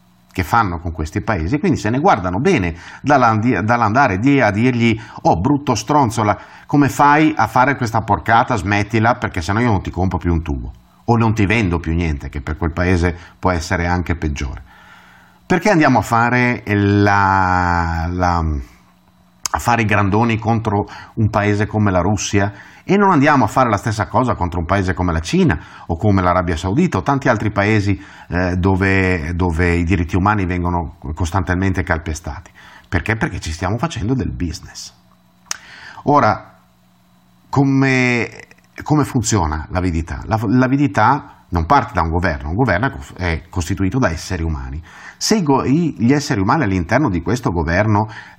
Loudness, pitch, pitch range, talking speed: -17 LUFS, 100 Hz, 85-115 Hz, 155 wpm